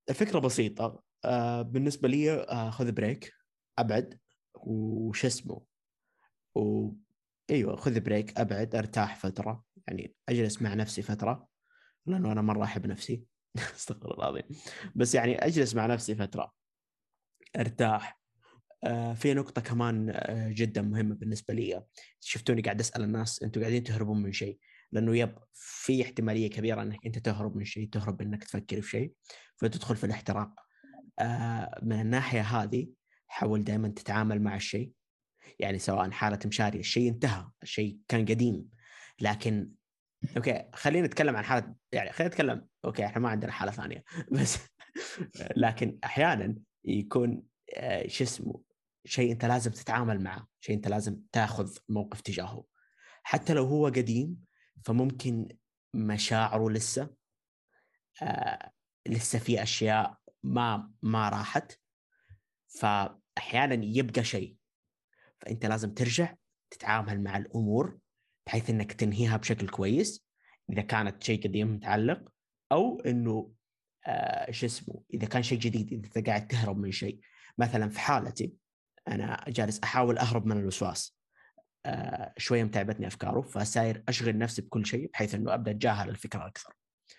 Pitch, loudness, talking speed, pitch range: 110 Hz, -31 LUFS, 130 wpm, 105-120 Hz